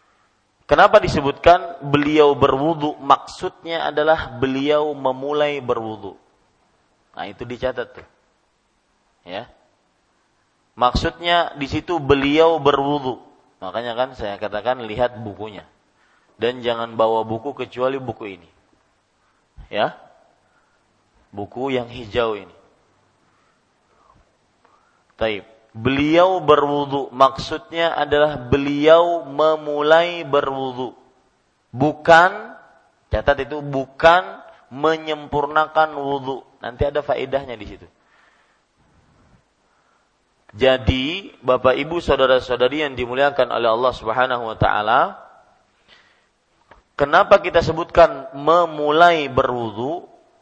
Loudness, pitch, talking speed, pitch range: -18 LUFS, 140 Hz, 85 wpm, 125-155 Hz